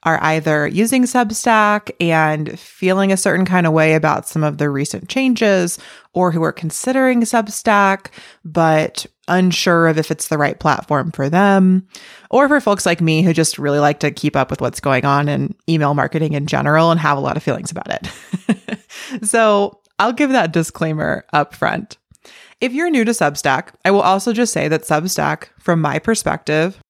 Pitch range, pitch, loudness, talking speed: 155-210 Hz, 170 Hz, -16 LUFS, 185 wpm